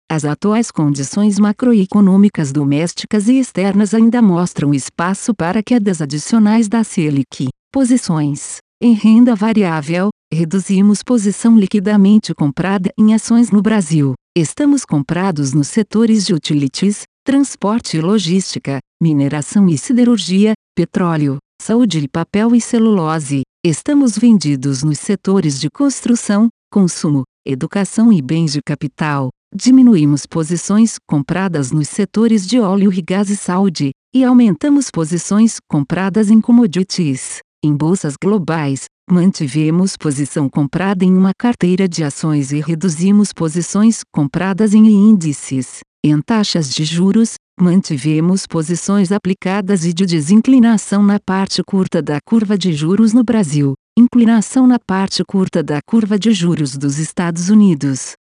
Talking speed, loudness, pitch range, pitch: 125 wpm, -14 LUFS, 155-215 Hz, 190 Hz